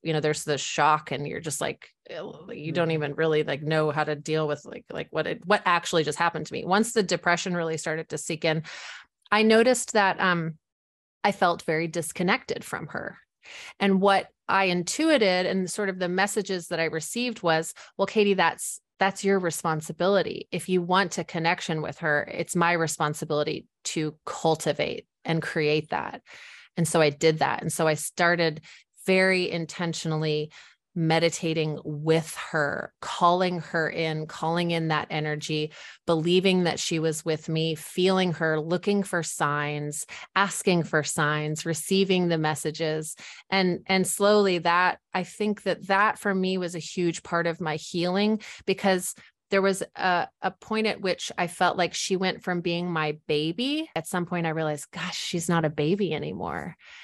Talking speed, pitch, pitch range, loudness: 175 wpm, 170 Hz, 155-190 Hz, -26 LUFS